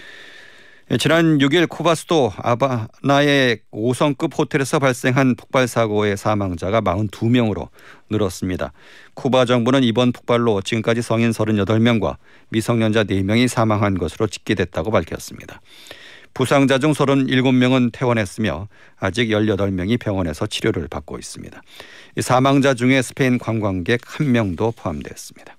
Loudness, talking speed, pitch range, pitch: -18 LUFS, 300 characters per minute, 105-130 Hz, 120 Hz